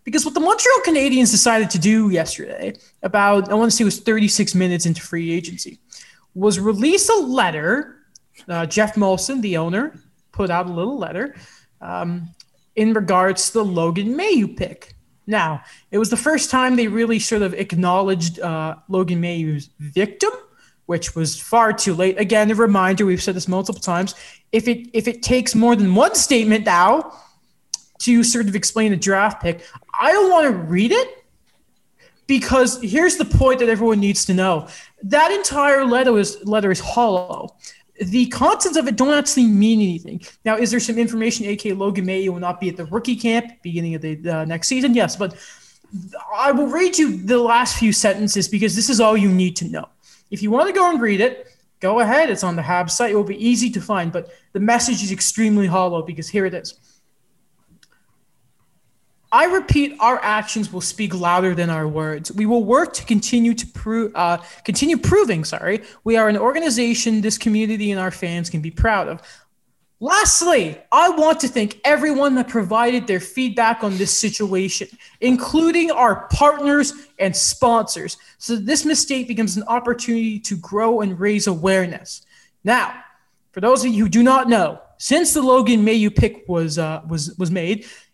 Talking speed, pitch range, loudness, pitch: 185 wpm, 185-245 Hz, -18 LUFS, 215 Hz